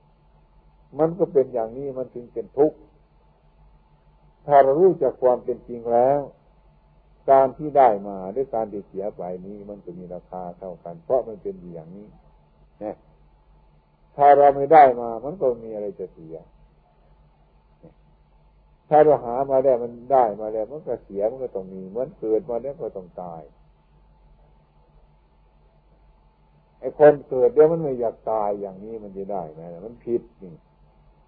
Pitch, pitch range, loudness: 110 Hz, 85-130 Hz, -21 LUFS